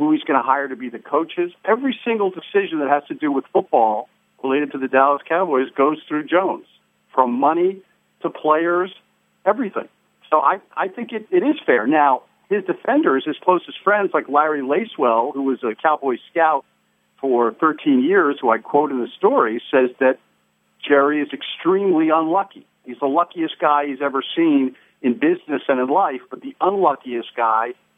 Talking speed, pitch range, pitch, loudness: 180 wpm, 135-205 Hz, 155 Hz, -19 LUFS